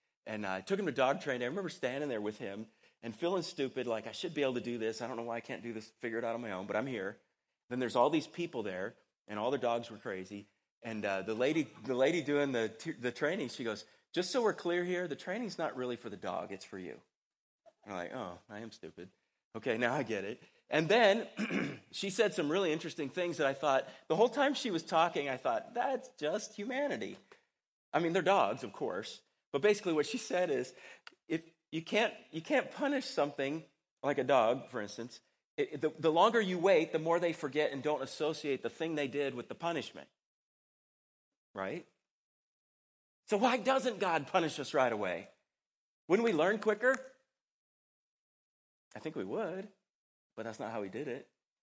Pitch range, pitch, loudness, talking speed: 115-195 Hz, 155 Hz, -35 LUFS, 215 wpm